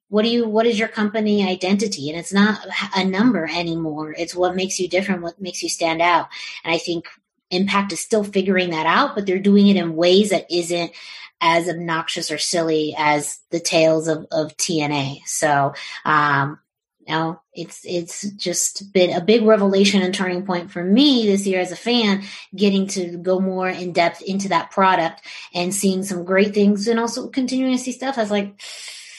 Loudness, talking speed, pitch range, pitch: -19 LUFS, 195 wpm, 170-205 Hz, 185 Hz